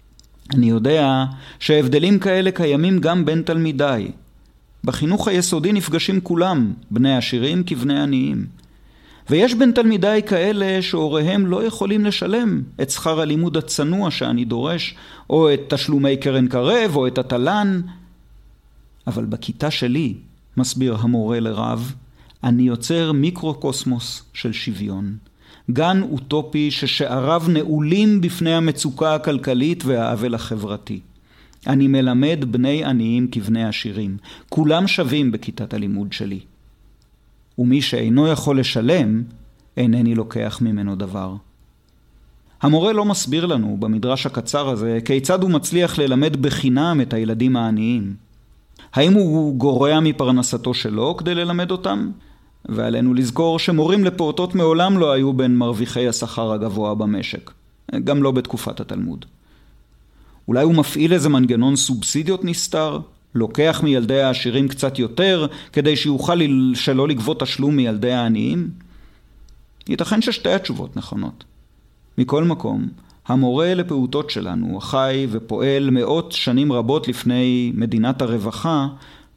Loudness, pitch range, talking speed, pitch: -19 LUFS, 120-160 Hz, 115 wpm, 135 Hz